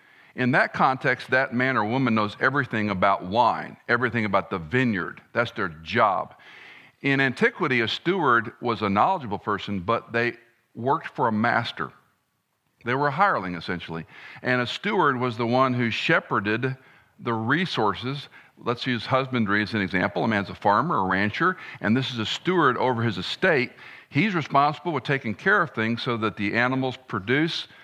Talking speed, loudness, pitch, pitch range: 170 wpm, -24 LUFS, 120 Hz, 105-130 Hz